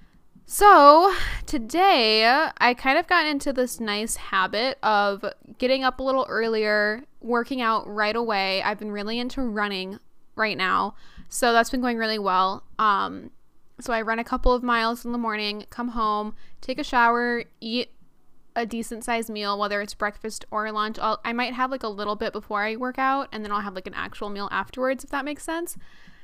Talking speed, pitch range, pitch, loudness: 190 wpm, 210-255 Hz, 230 Hz, -23 LUFS